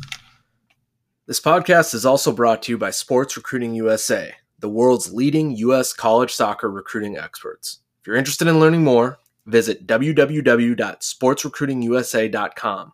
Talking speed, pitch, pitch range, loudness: 125 wpm, 125 Hz, 120-150 Hz, -19 LUFS